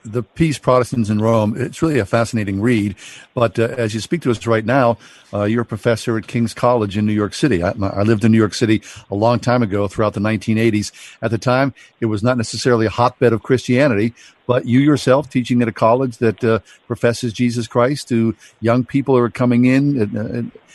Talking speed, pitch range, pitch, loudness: 220 wpm, 110-125 Hz, 115 Hz, -17 LUFS